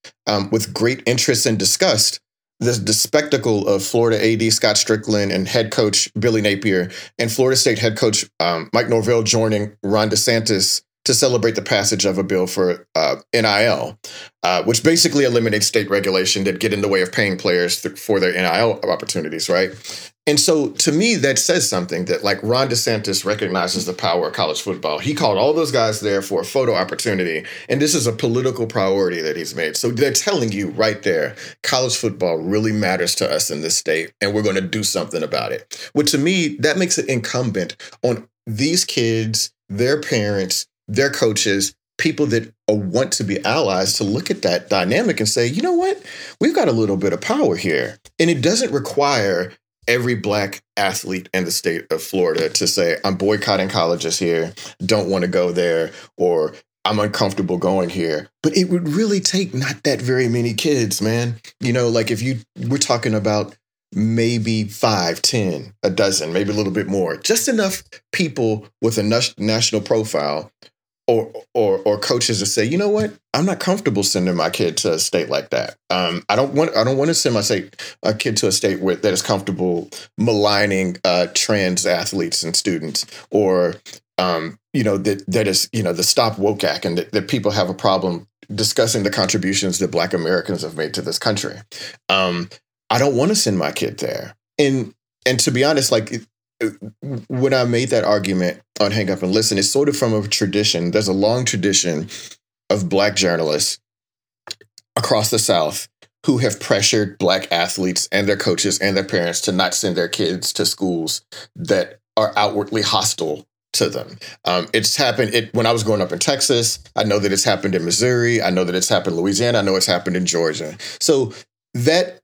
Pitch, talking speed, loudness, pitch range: 110 Hz, 195 wpm, -18 LUFS, 100-125 Hz